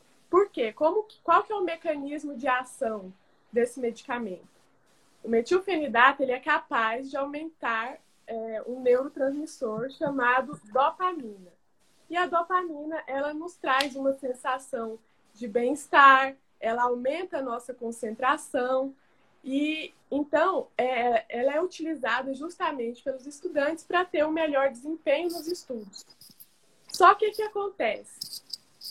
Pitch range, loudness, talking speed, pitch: 245-320 Hz, -27 LUFS, 125 wpm, 275 Hz